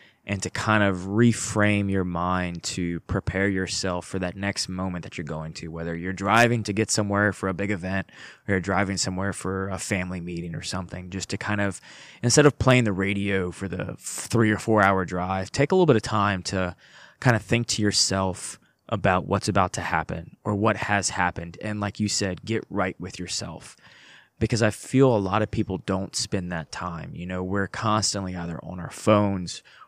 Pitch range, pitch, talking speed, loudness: 90-105 Hz, 100 Hz, 205 wpm, -25 LUFS